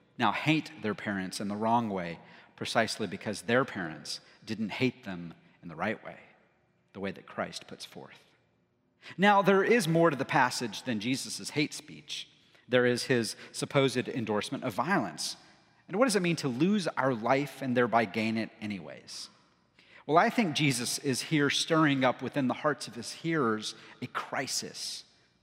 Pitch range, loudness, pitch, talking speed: 110-150 Hz, -30 LUFS, 130 Hz, 170 wpm